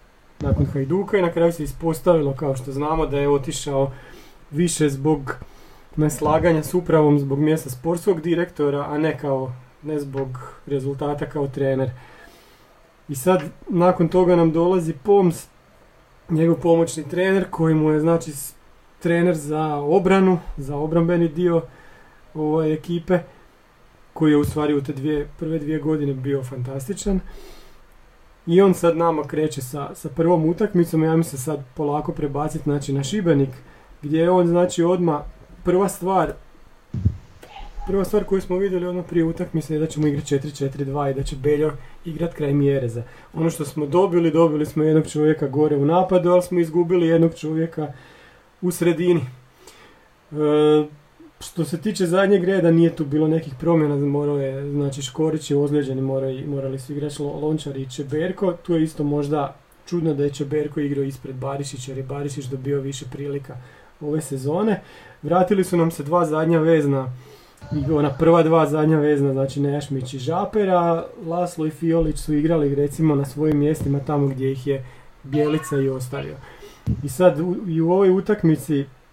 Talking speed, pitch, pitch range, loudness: 160 wpm, 155 Hz, 145-170 Hz, -21 LUFS